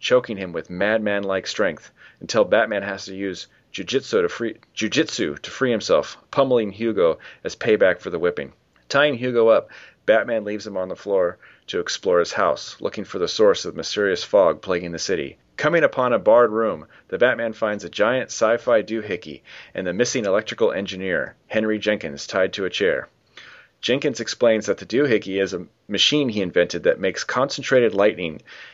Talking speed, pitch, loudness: 175 wpm, 120 Hz, -21 LUFS